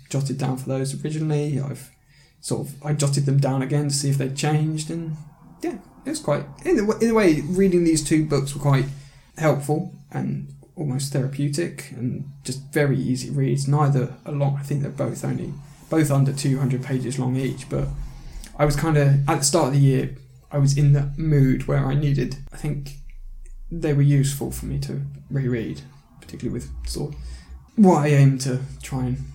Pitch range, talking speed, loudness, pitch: 130-150 Hz, 200 wpm, -22 LUFS, 140 Hz